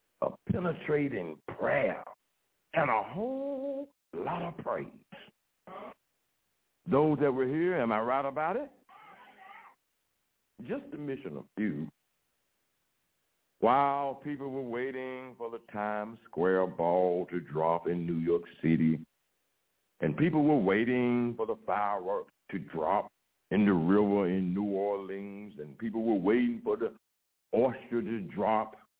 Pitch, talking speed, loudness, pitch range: 120 Hz, 130 wpm, -31 LUFS, 100-155 Hz